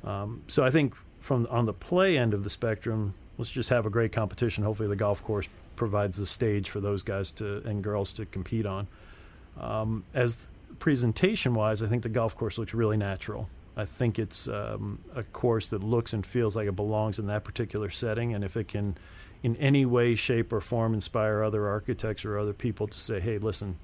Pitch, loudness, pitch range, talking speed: 110 Hz, -29 LUFS, 100-115 Hz, 205 wpm